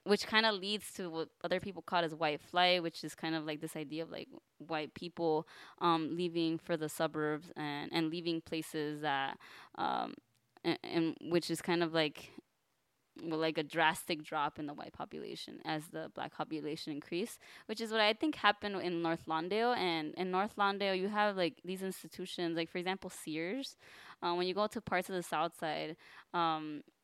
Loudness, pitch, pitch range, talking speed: -36 LUFS, 170 Hz, 160-185 Hz, 195 wpm